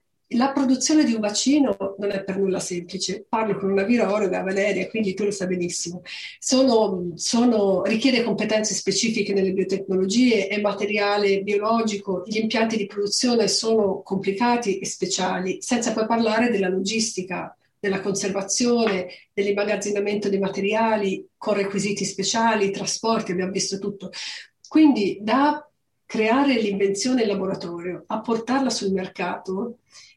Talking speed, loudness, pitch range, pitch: 130 wpm, -22 LUFS, 195-225 Hz, 205 Hz